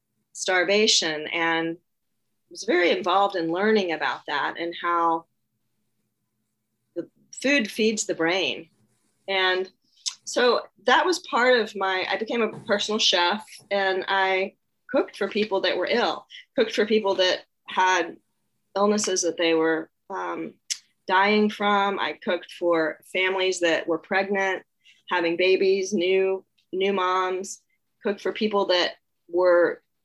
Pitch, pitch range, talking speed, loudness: 190 Hz, 170-205 Hz, 130 wpm, -23 LUFS